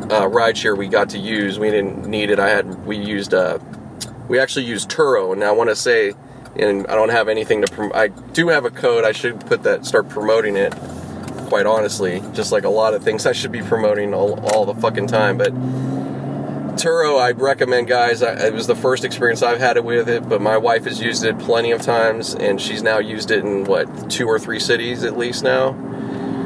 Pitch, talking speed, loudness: 120 Hz, 225 wpm, -18 LUFS